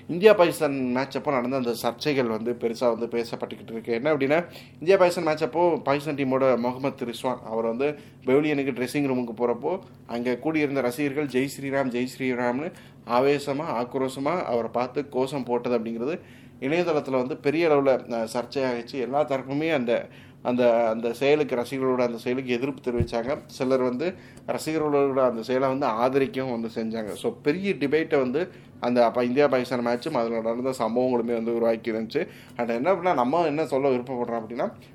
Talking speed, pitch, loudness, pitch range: 155 wpm, 130 Hz, -25 LUFS, 120-140 Hz